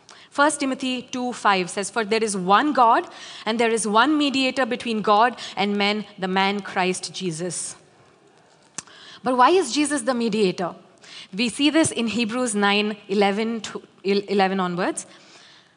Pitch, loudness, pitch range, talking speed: 220 Hz, -22 LUFS, 195-250 Hz, 135 wpm